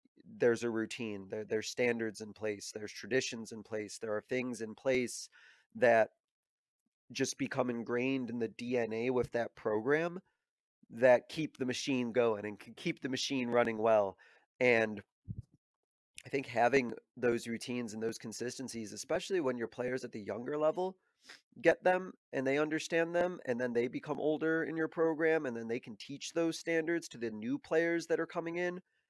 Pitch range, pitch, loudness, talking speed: 115-160 Hz, 125 Hz, -34 LUFS, 175 wpm